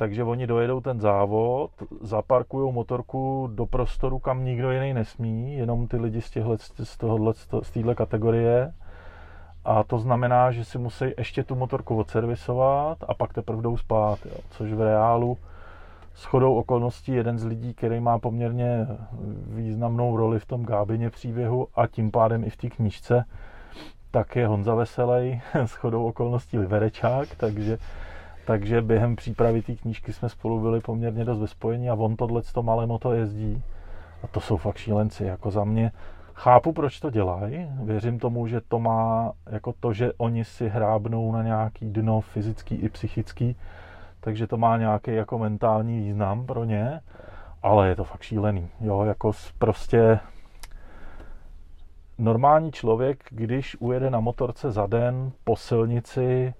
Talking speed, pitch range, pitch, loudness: 155 wpm, 105-120 Hz, 115 Hz, -25 LUFS